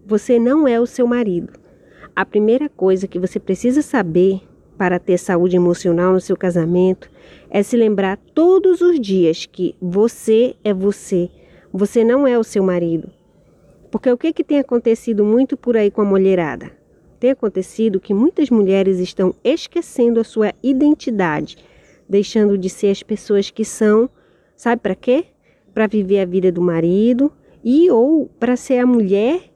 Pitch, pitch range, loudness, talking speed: 210 Hz, 185-245 Hz, -16 LUFS, 165 wpm